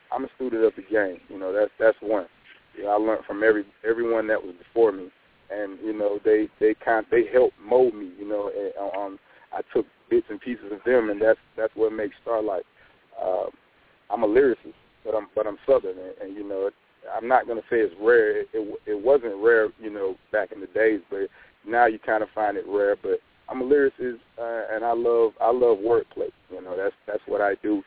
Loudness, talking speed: -24 LUFS, 230 wpm